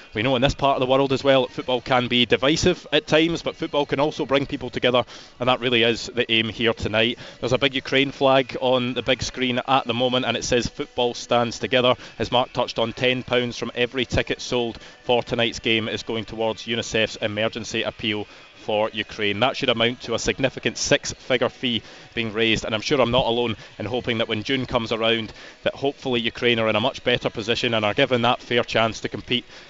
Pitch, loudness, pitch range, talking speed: 120 Hz, -22 LUFS, 115-130 Hz, 220 wpm